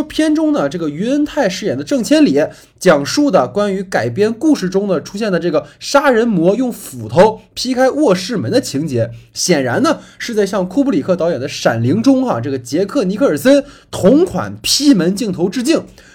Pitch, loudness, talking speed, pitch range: 210 Hz, -14 LUFS, 285 characters per minute, 175-275 Hz